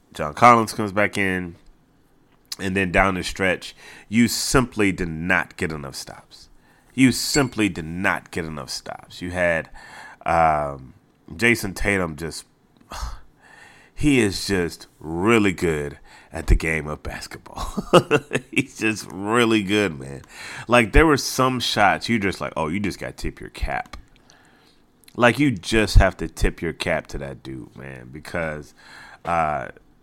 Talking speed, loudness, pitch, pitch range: 150 wpm, -21 LUFS, 95 Hz, 80-110 Hz